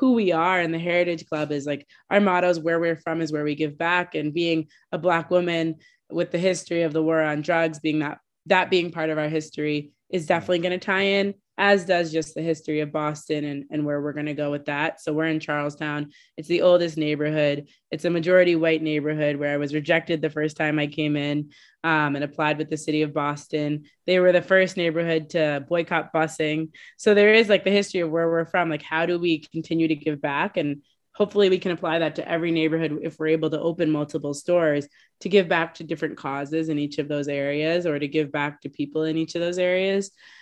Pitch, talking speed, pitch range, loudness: 160 Hz, 235 wpm, 150-175 Hz, -23 LUFS